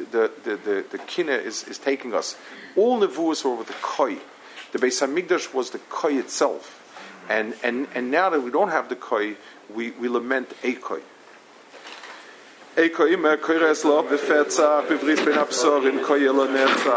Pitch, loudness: 150 Hz, -22 LUFS